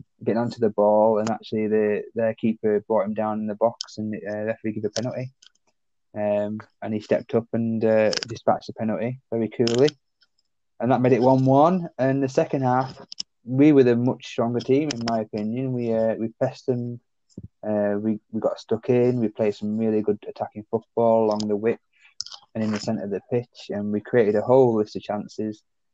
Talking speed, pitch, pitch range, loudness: 200 wpm, 115 Hz, 105-125 Hz, -23 LUFS